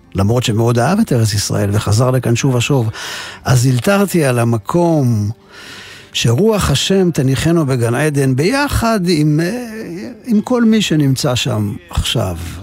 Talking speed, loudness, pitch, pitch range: 130 wpm, -14 LUFS, 135 Hz, 115-175 Hz